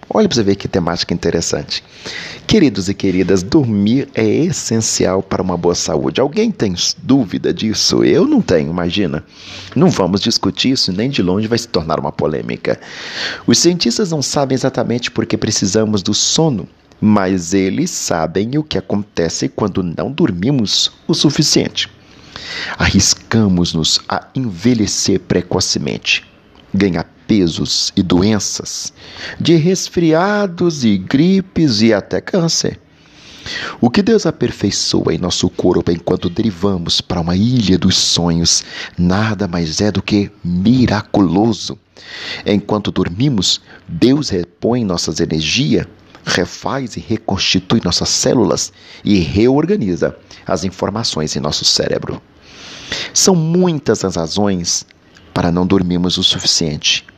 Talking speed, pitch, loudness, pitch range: 125 wpm, 100 Hz, -15 LUFS, 90-125 Hz